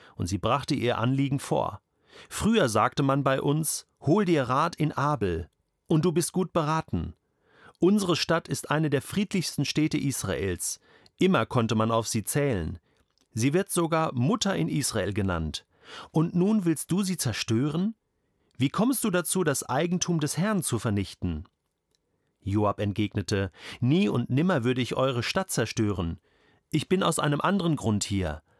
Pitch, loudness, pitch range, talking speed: 135 Hz, -27 LUFS, 105-170 Hz, 155 wpm